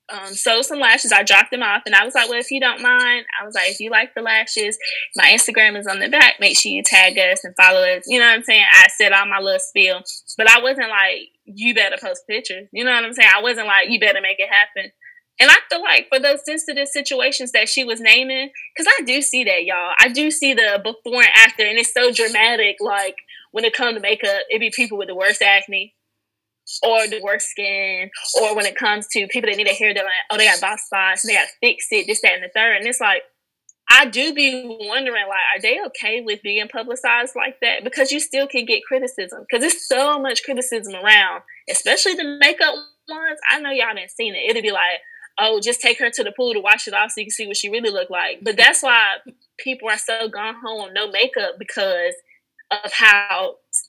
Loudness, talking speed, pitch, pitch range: -15 LUFS, 245 wpm, 230 Hz, 205-280 Hz